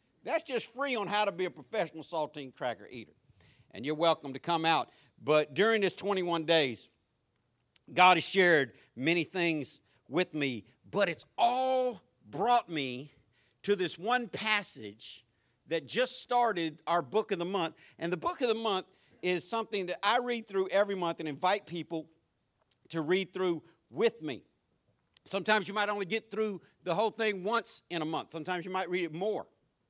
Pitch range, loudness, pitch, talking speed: 150-205 Hz, -31 LUFS, 175 Hz, 175 wpm